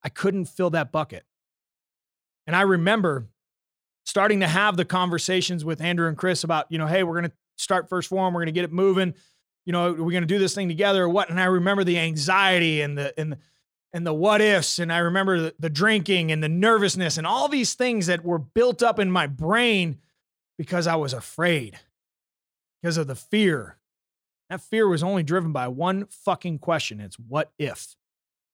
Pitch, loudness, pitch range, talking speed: 175 Hz, -23 LUFS, 160-195 Hz, 200 wpm